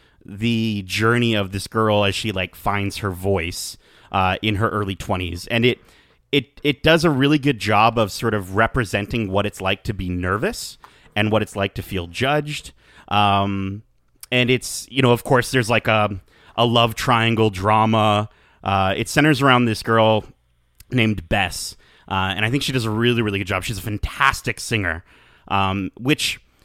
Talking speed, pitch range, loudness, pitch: 180 wpm, 100-120 Hz, -20 LUFS, 110 Hz